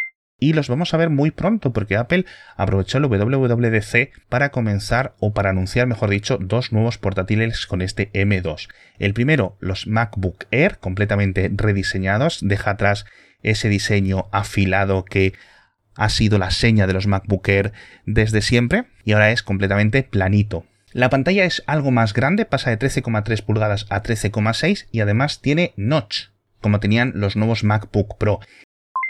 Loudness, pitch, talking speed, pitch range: -19 LUFS, 105 Hz, 155 wpm, 100-125 Hz